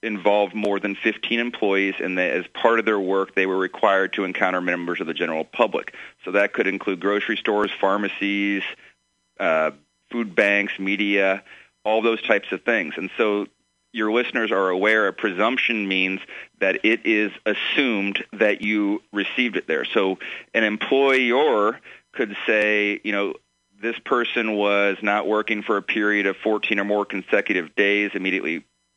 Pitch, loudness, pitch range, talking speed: 100 Hz, -22 LUFS, 95-110 Hz, 160 wpm